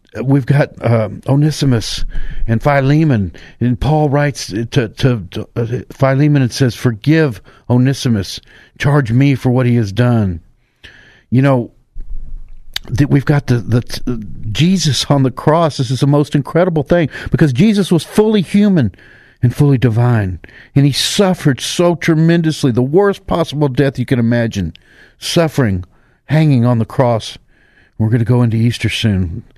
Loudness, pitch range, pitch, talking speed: -14 LUFS, 115-150 Hz, 130 Hz, 150 wpm